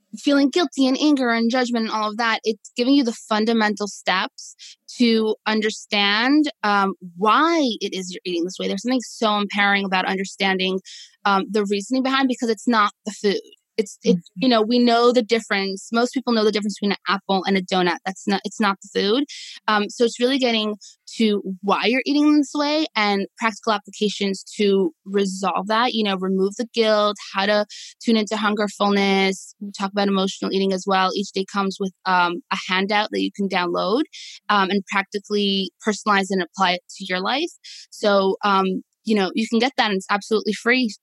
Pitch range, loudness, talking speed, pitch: 195-230 Hz, -21 LUFS, 195 wpm, 210 Hz